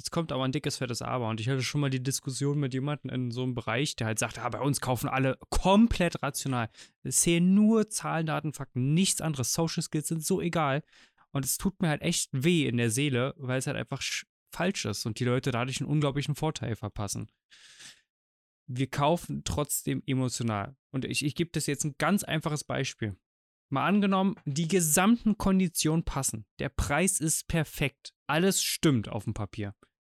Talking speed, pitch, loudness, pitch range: 195 wpm, 140 Hz, -29 LUFS, 125-160 Hz